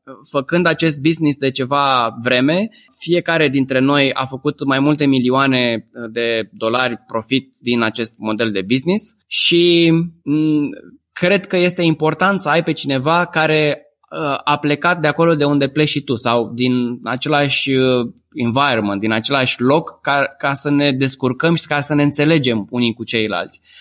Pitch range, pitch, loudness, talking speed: 125-155 Hz, 140 Hz, -16 LUFS, 150 wpm